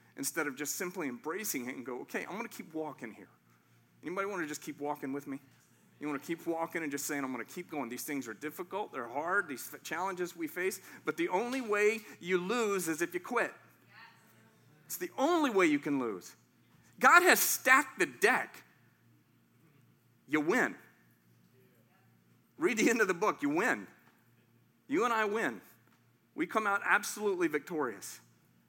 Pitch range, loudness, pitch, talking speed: 140-210 Hz, -32 LUFS, 165 Hz, 180 wpm